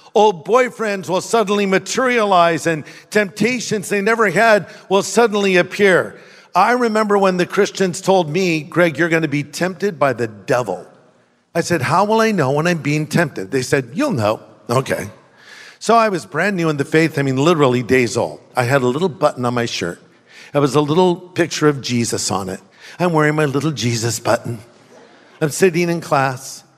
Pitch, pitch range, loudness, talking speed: 170 Hz, 140-200 Hz, -17 LUFS, 190 wpm